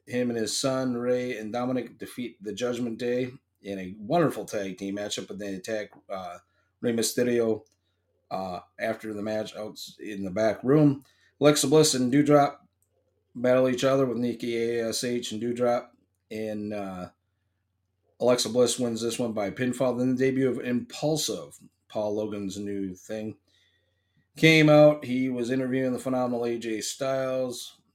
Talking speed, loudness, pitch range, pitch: 150 wpm, -26 LUFS, 105-130 Hz, 120 Hz